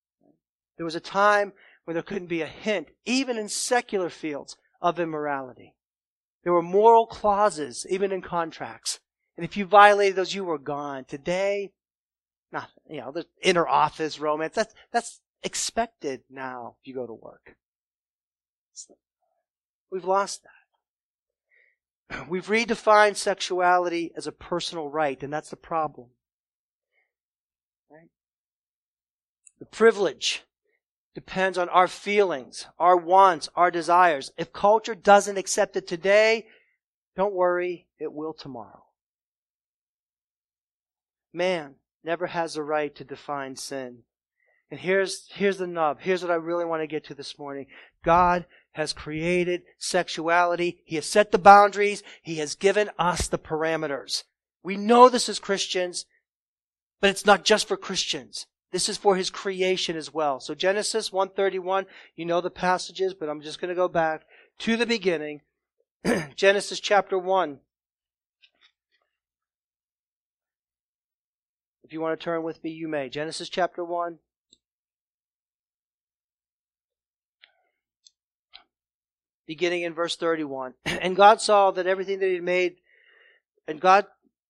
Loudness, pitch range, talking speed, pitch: -24 LUFS, 130-195 Hz, 135 wpm, 170 Hz